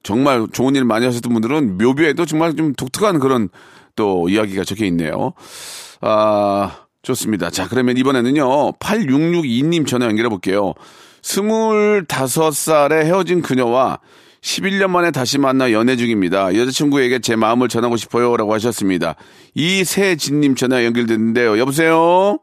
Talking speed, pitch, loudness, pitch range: 315 characters per minute, 130 Hz, -16 LUFS, 115-155 Hz